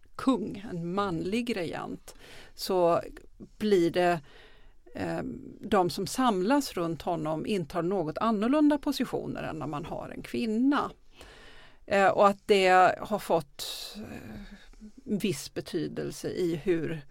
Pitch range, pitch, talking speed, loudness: 175-230 Hz, 200 Hz, 120 wpm, -28 LUFS